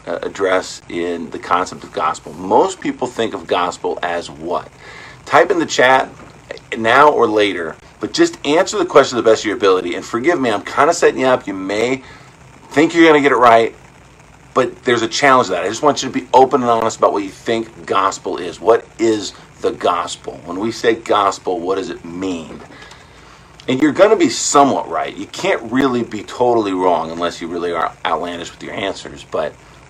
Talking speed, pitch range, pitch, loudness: 210 wpm, 90-135 Hz, 115 Hz, -16 LUFS